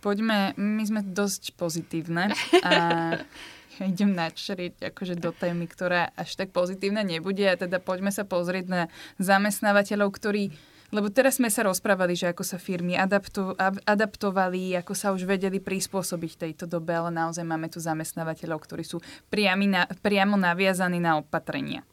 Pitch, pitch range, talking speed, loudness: 190 Hz, 175-200 Hz, 155 wpm, -26 LUFS